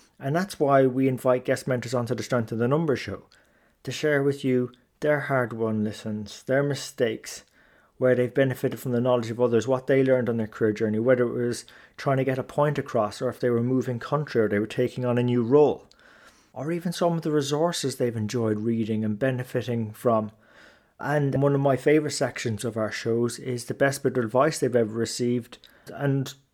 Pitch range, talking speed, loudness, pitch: 120-140 Hz, 210 wpm, -25 LUFS, 125 Hz